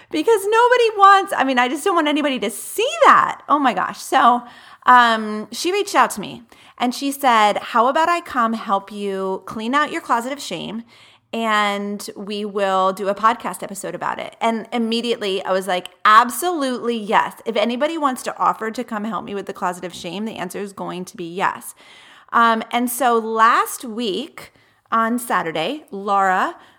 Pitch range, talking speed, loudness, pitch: 200-265 Hz, 185 wpm, -18 LUFS, 230 Hz